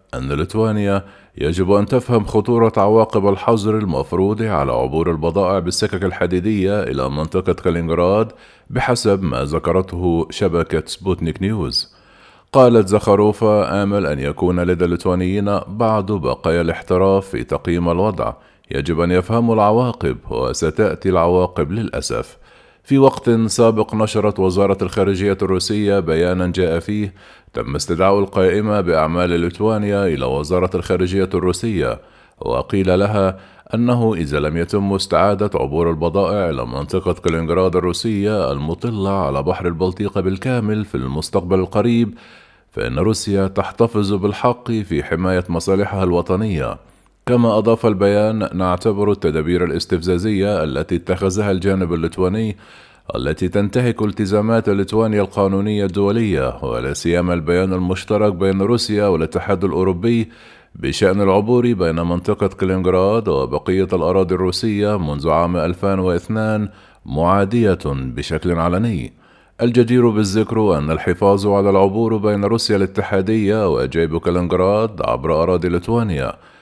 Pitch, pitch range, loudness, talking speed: 95 Hz, 90-105 Hz, -17 LUFS, 110 wpm